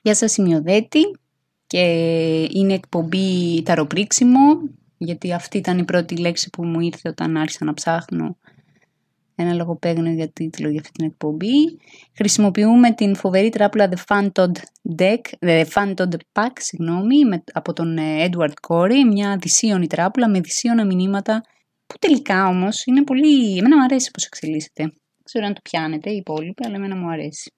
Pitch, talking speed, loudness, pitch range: 185 Hz, 155 wpm, -18 LUFS, 165-215 Hz